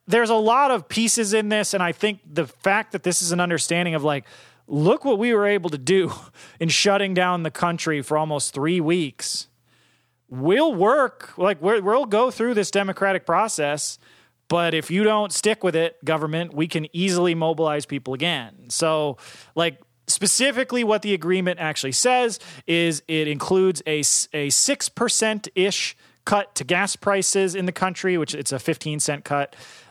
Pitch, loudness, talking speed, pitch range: 175 Hz, -21 LUFS, 175 wpm, 155-200 Hz